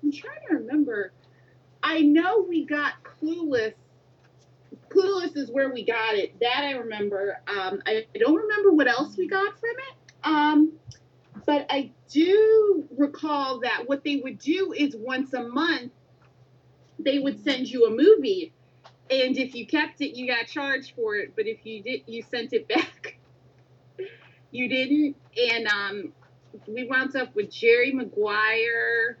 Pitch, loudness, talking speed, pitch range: 270 Hz, -24 LUFS, 160 wpm, 230-315 Hz